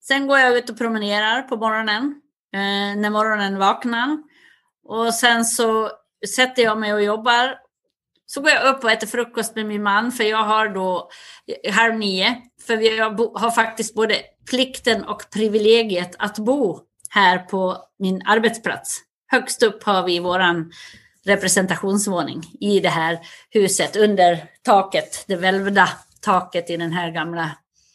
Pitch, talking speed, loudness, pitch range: 215 Hz, 150 wpm, -19 LUFS, 195-235 Hz